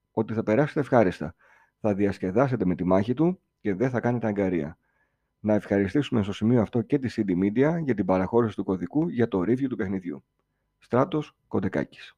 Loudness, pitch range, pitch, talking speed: -26 LUFS, 100-130 Hz, 110 Hz, 175 wpm